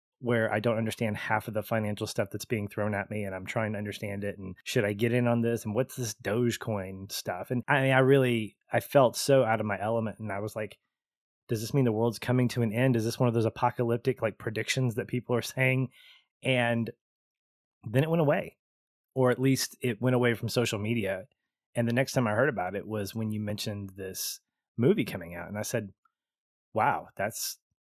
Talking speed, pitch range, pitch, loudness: 225 wpm, 105-125 Hz, 115 Hz, -29 LUFS